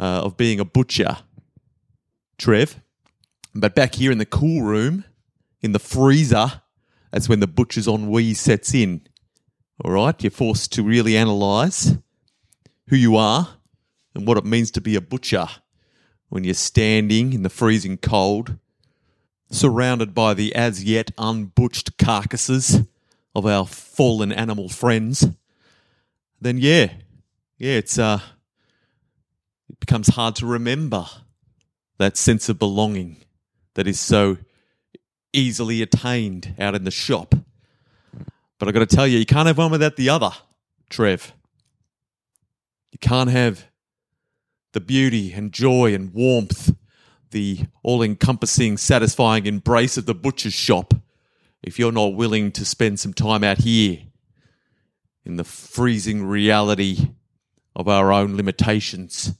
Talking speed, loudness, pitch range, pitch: 135 wpm, -19 LUFS, 105-125 Hz, 115 Hz